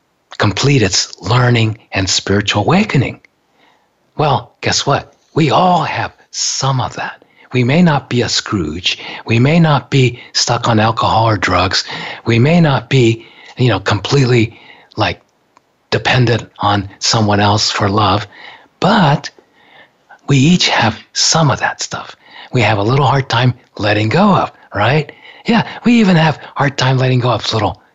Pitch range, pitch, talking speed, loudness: 110-140 Hz, 120 Hz, 155 wpm, -13 LUFS